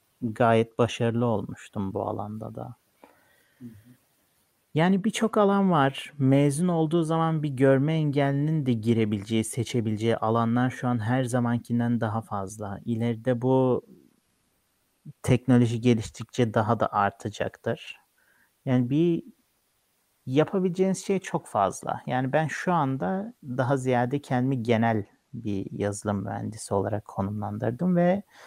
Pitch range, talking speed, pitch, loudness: 115-145 Hz, 110 wpm, 125 Hz, -26 LUFS